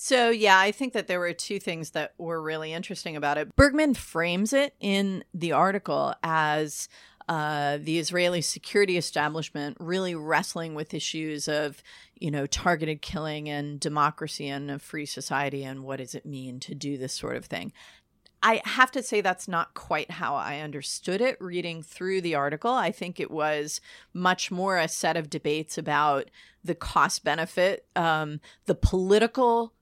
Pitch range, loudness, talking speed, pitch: 150-185 Hz, -27 LUFS, 170 wpm, 160 Hz